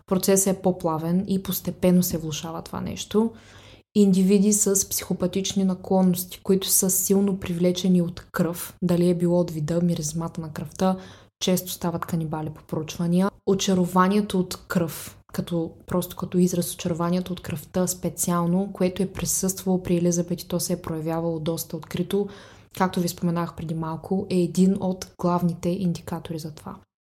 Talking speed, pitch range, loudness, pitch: 150 wpm, 170-190 Hz, -24 LUFS, 180 Hz